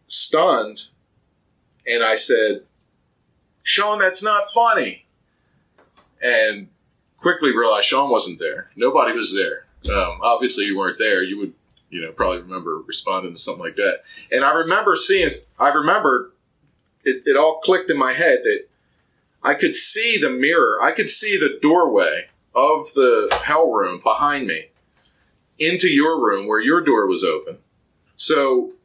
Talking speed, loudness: 150 wpm, -18 LUFS